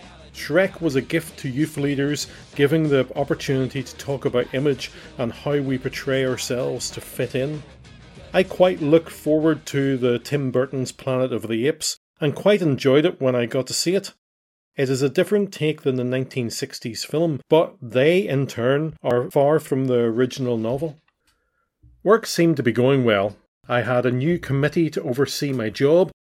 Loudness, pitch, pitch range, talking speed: -22 LUFS, 135 Hz, 125-155 Hz, 180 wpm